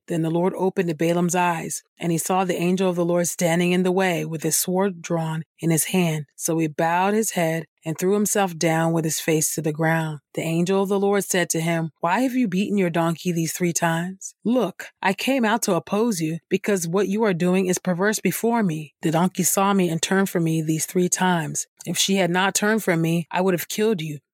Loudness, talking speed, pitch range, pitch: -22 LUFS, 235 wpm, 165-195 Hz, 180 Hz